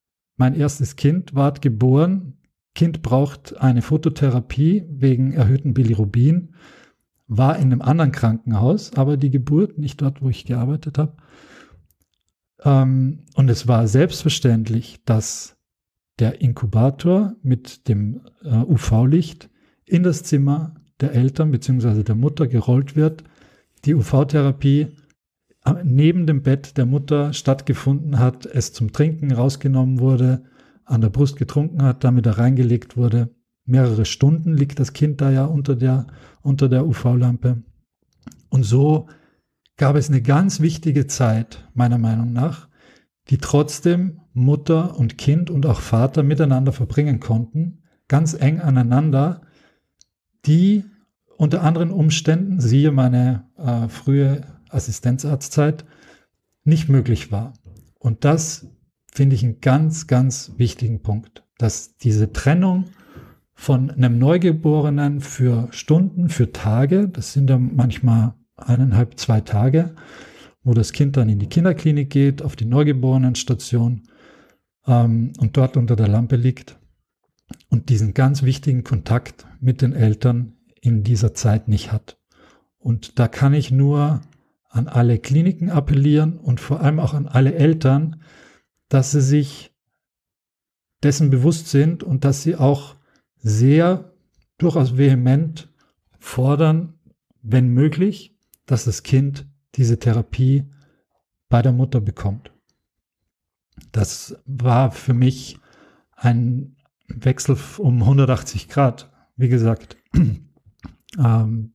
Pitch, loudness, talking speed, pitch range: 135 Hz, -18 LUFS, 125 wpm, 120-150 Hz